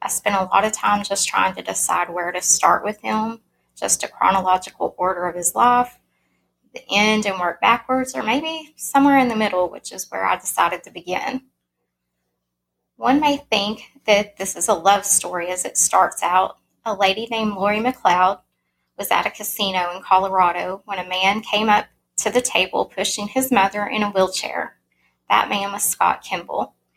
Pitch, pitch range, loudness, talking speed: 200 Hz, 180-220 Hz, -19 LUFS, 185 wpm